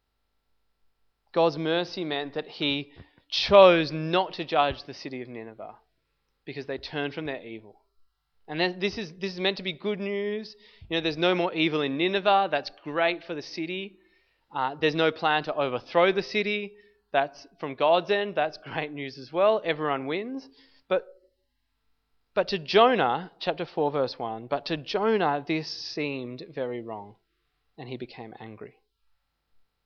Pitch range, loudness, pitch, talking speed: 135-190 Hz, -26 LUFS, 160 Hz, 160 wpm